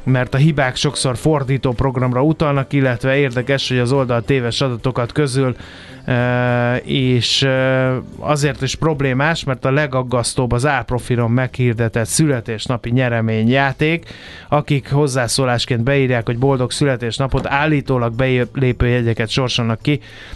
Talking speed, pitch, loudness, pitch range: 110 wpm, 130 Hz, -17 LUFS, 120-140 Hz